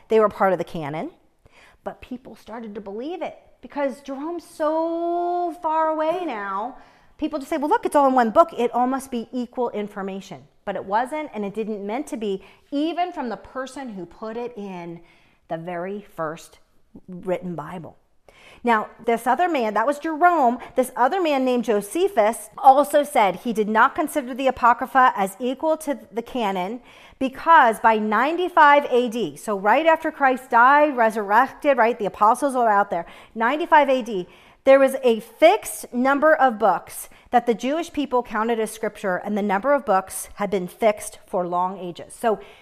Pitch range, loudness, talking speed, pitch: 205-290 Hz, -21 LUFS, 175 wpm, 240 Hz